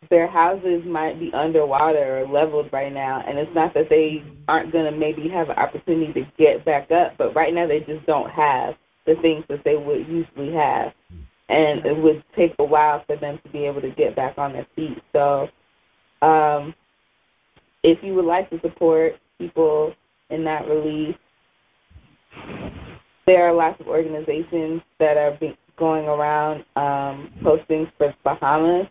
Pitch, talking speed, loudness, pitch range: 155 Hz, 170 wpm, -20 LUFS, 150-165 Hz